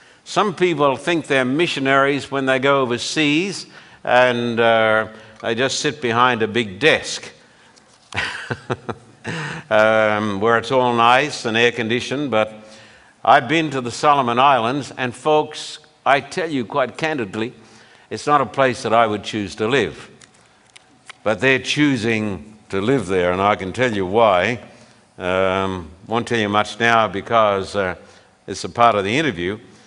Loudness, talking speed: -18 LUFS, 155 wpm